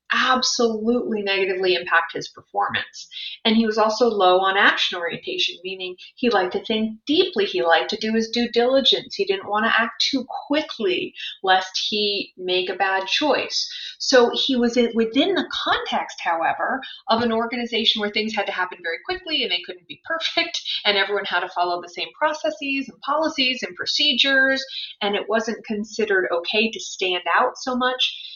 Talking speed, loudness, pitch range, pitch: 175 wpm, -21 LUFS, 200-295 Hz, 230 Hz